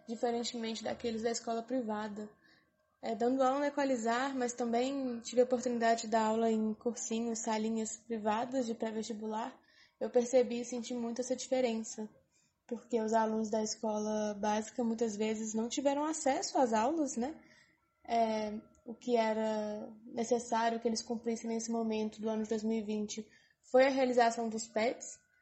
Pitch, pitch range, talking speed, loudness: 230 Hz, 220-245 Hz, 150 wpm, -34 LUFS